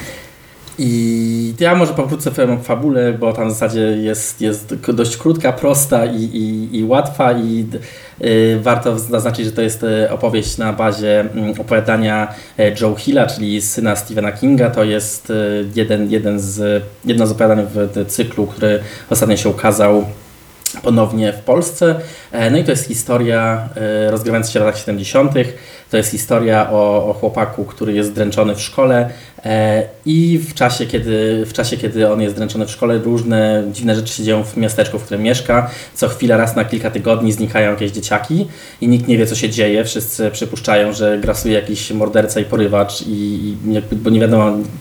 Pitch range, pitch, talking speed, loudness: 105-115 Hz, 110 Hz, 170 wpm, -15 LUFS